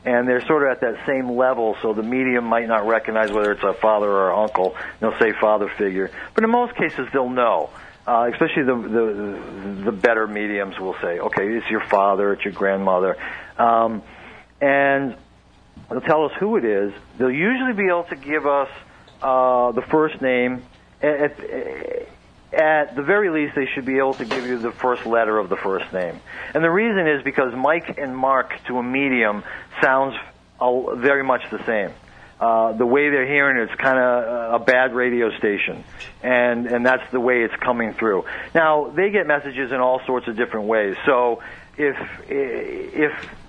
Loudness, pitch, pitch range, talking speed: -20 LUFS, 125 Hz, 110-140 Hz, 190 wpm